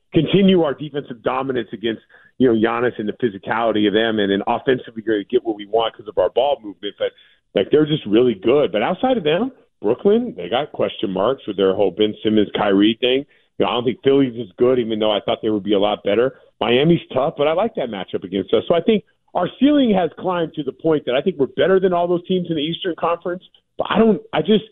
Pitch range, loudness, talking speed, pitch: 115-185 Hz, -19 LUFS, 250 wpm, 140 Hz